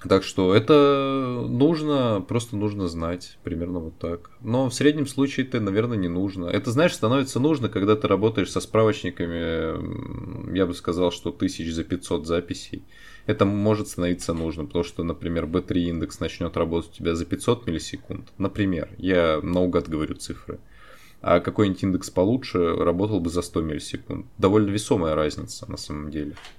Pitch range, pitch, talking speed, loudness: 85-115 Hz, 95 Hz, 160 wpm, -24 LUFS